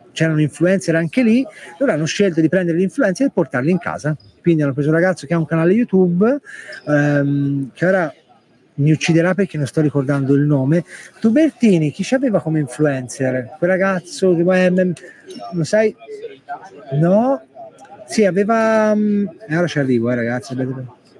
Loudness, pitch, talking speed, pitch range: -17 LUFS, 170 Hz, 160 wpm, 145-205 Hz